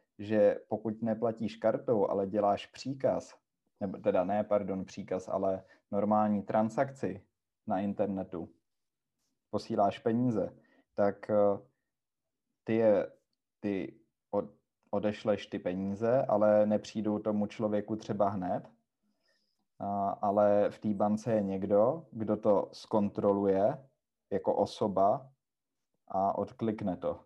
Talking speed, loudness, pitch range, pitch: 105 wpm, -32 LUFS, 100-110 Hz, 105 Hz